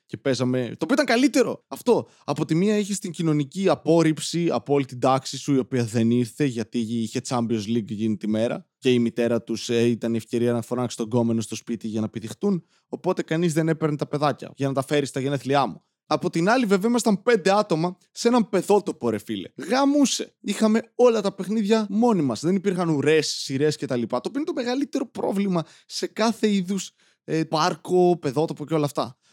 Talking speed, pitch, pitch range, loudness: 205 wpm, 155 Hz, 125-195 Hz, -23 LUFS